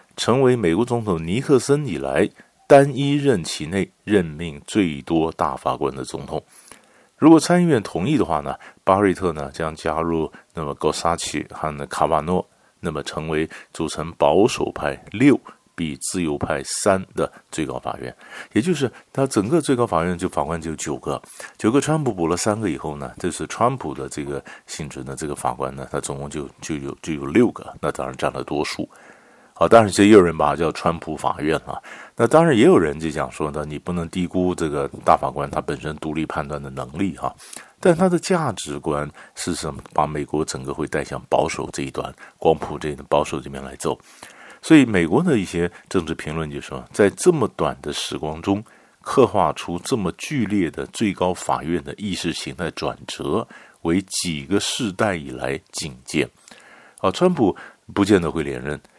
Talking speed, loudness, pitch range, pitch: 275 characters per minute, -21 LUFS, 75-105 Hz, 85 Hz